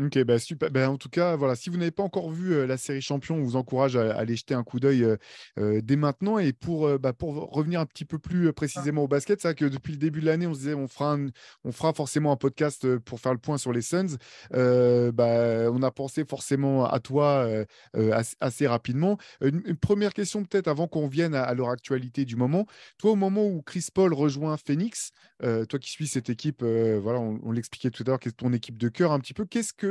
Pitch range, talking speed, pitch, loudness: 125-160 Hz, 255 wpm, 140 Hz, -27 LUFS